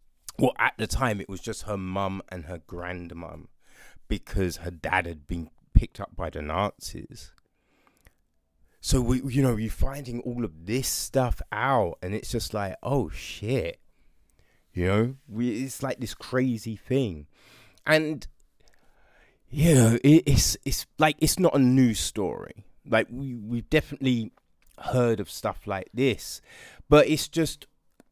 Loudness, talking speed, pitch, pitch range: -26 LUFS, 155 wpm, 115 Hz, 90-130 Hz